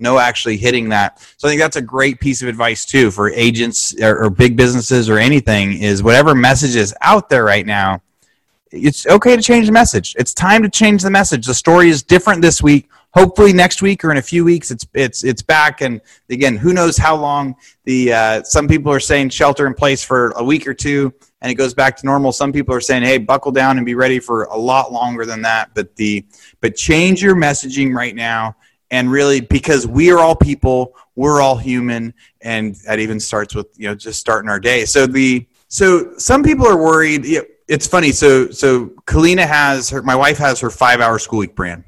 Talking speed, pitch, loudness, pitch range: 220 wpm, 130 Hz, -13 LUFS, 115-150 Hz